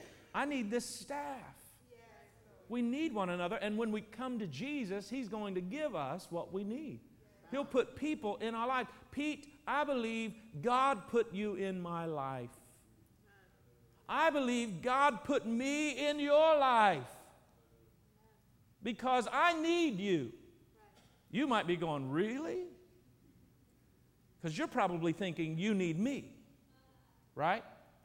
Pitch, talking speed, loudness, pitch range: 230 Hz, 135 wpm, -36 LUFS, 180-275 Hz